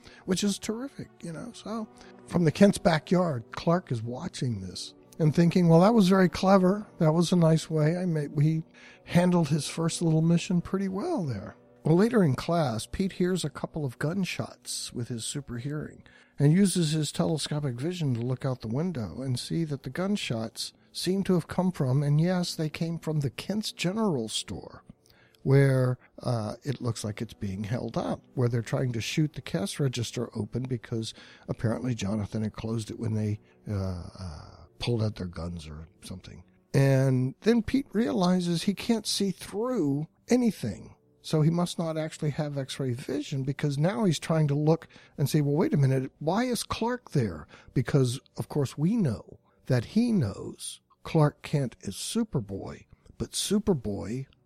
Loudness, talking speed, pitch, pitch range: -28 LUFS, 180 wpm, 145 Hz, 120-175 Hz